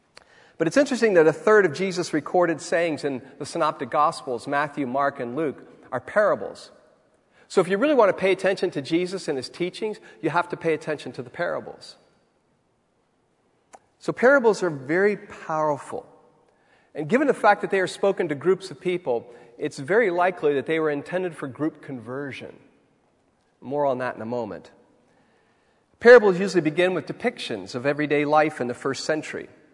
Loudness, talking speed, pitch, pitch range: -23 LUFS, 175 wpm, 160 Hz, 145-185 Hz